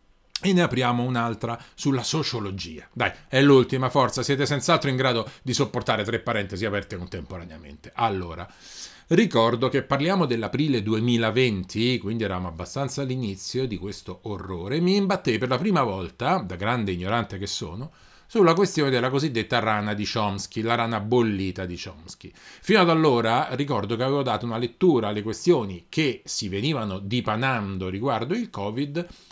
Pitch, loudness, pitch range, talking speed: 115 Hz, -24 LUFS, 100-135 Hz, 150 wpm